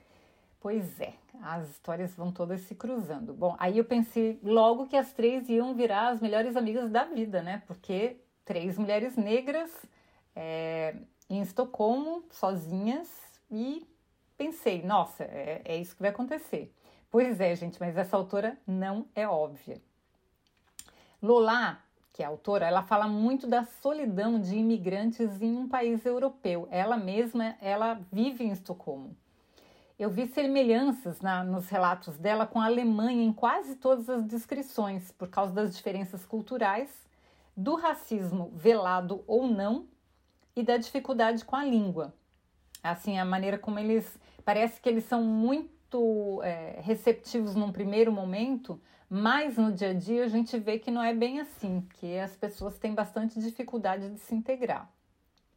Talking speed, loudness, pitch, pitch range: 150 wpm, -30 LUFS, 220 Hz, 190-240 Hz